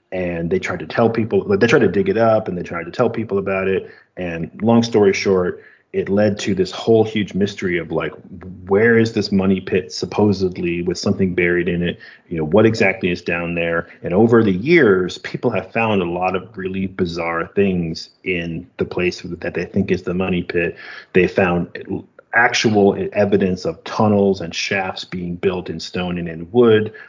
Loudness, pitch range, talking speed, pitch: -18 LUFS, 90-115 Hz, 195 wpm, 95 Hz